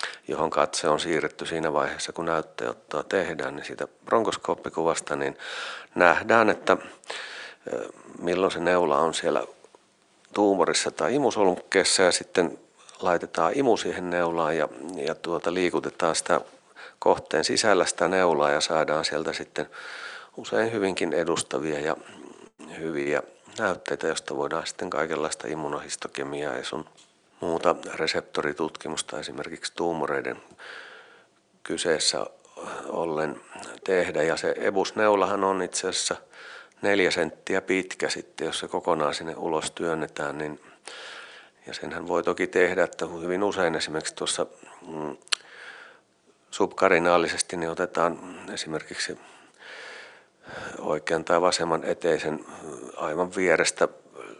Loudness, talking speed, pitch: -26 LUFS, 110 wpm, 90 Hz